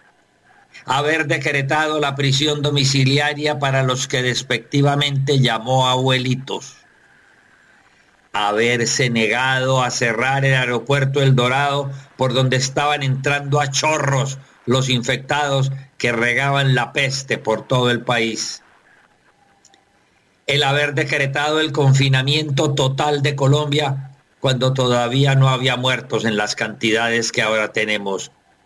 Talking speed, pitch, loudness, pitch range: 115 wpm, 135 Hz, -18 LUFS, 125-145 Hz